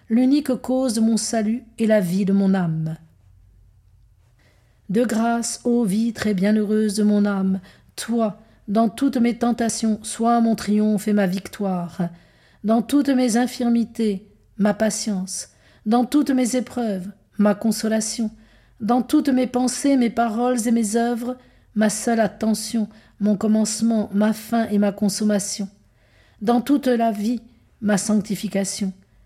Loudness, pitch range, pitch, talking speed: -21 LUFS, 200-235 Hz, 220 Hz, 140 wpm